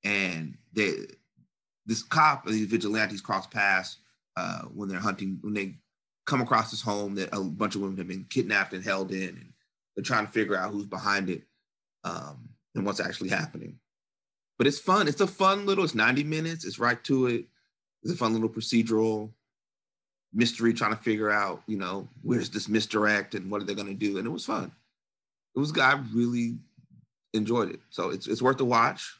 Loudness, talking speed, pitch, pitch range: -28 LUFS, 195 wpm, 110 Hz, 100-120 Hz